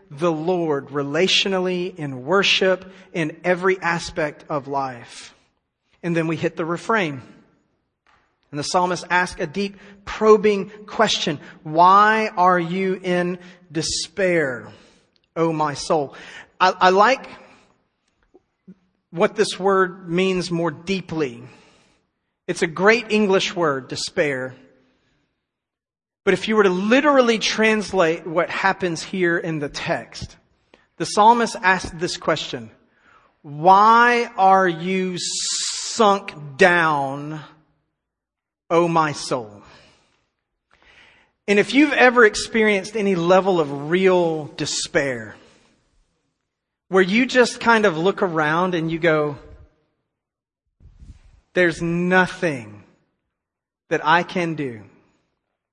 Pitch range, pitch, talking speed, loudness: 160-195 Hz, 180 Hz, 110 wpm, -19 LUFS